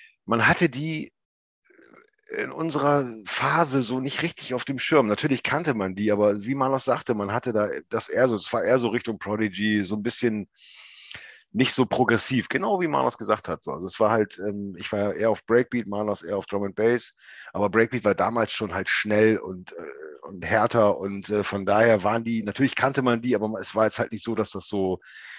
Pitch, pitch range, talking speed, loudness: 115 Hz, 105-130 Hz, 205 wpm, -24 LUFS